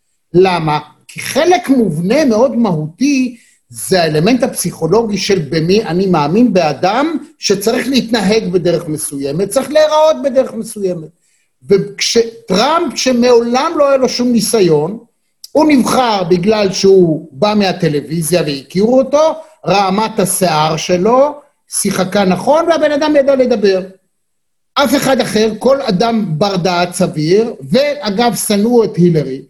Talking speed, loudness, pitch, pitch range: 120 wpm, -12 LUFS, 210 Hz, 180-255 Hz